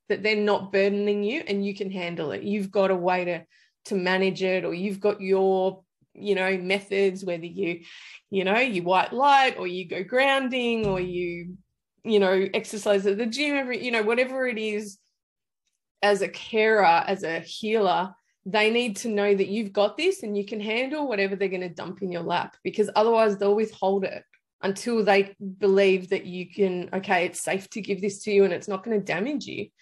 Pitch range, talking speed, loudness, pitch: 185-215 Hz, 205 wpm, -25 LUFS, 200 Hz